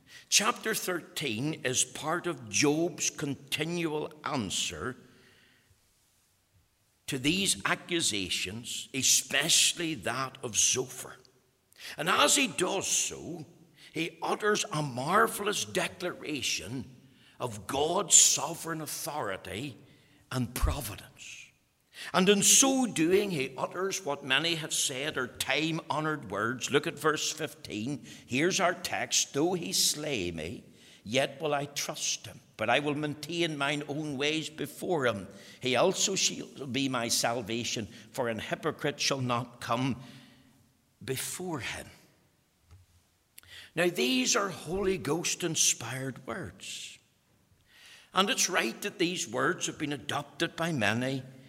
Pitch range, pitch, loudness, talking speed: 125-165 Hz, 145 Hz, -29 LUFS, 120 wpm